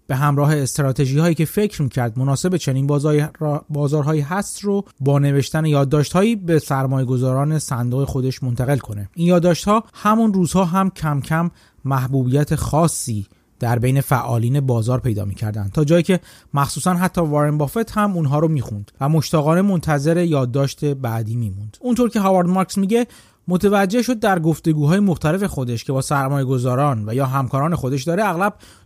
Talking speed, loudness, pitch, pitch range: 170 wpm, -19 LUFS, 145 Hz, 135-175 Hz